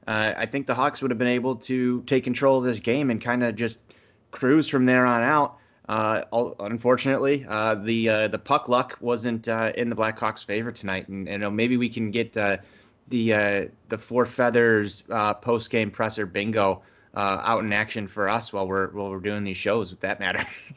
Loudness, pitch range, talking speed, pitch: -24 LUFS, 105-125 Hz, 215 wpm, 115 Hz